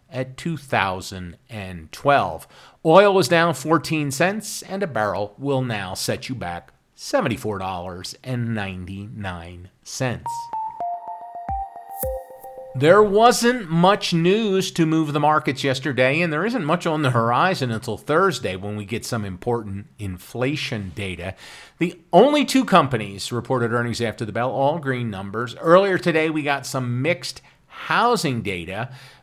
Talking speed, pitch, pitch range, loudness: 125 wpm, 135 Hz, 110-175 Hz, -21 LUFS